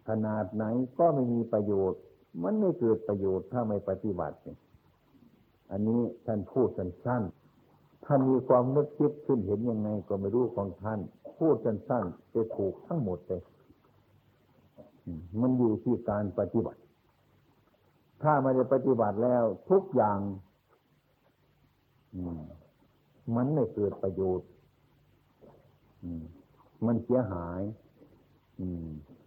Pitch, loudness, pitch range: 110 Hz, -30 LUFS, 95-125 Hz